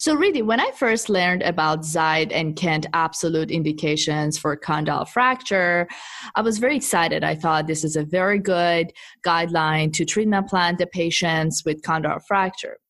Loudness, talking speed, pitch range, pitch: -21 LUFS, 165 wpm, 155-195 Hz, 170 Hz